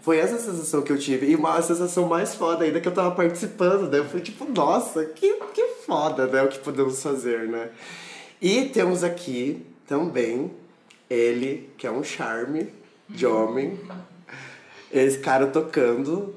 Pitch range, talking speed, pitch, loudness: 135-180 Hz, 160 wpm, 160 Hz, -24 LUFS